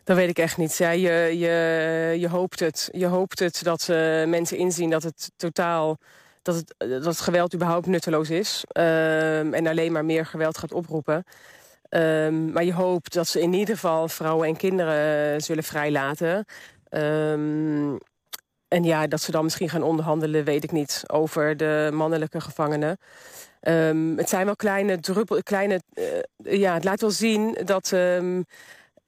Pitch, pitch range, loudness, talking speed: 165 Hz, 155-180 Hz, -24 LUFS, 170 wpm